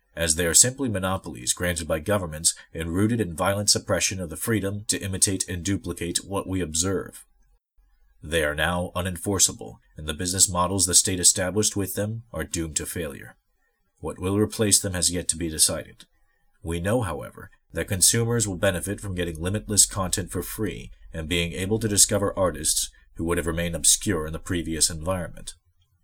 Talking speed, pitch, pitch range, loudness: 175 wpm, 90 Hz, 85-100 Hz, -23 LUFS